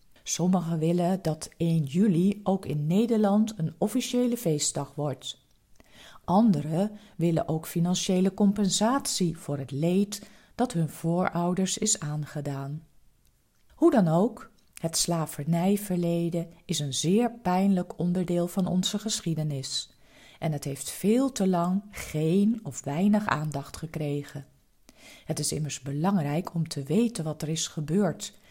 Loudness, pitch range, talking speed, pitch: -27 LUFS, 155-200 Hz, 125 wpm, 170 Hz